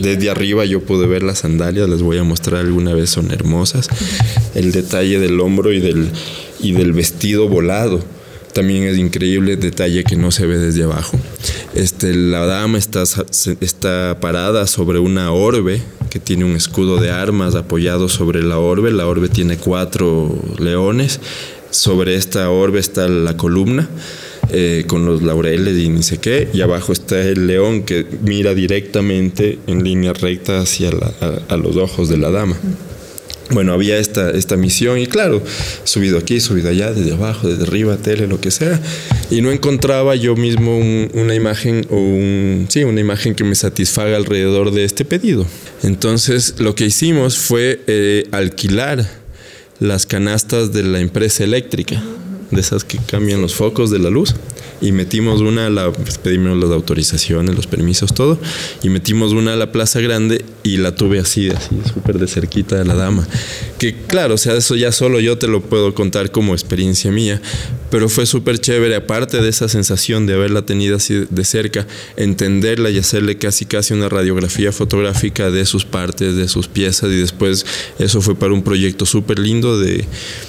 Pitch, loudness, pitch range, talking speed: 100 Hz, -15 LUFS, 90-110 Hz, 175 wpm